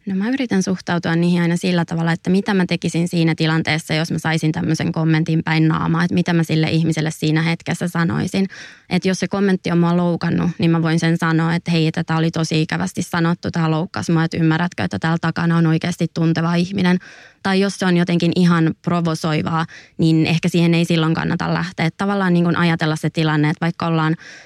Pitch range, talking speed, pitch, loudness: 160-175 Hz, 205 wpm, 165 Hz, -18 LUFS